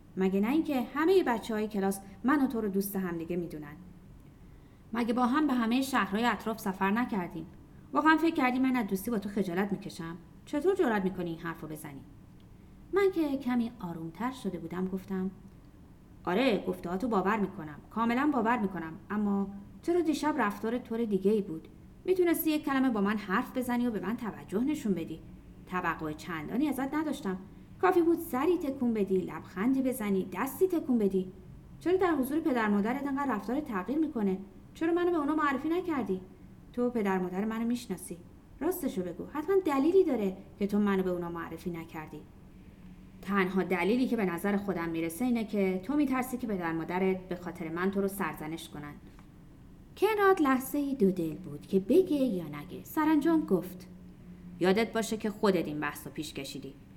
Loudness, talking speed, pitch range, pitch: -31 LUFS, 175 wpm, 180-265 Hz, 210 Hz